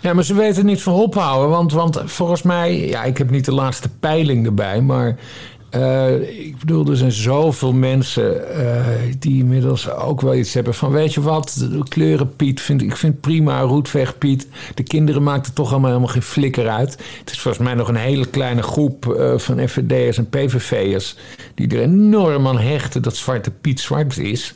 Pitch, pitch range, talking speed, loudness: 135 Hz, 125-150 Hz, 195 wpm, -17 LUFS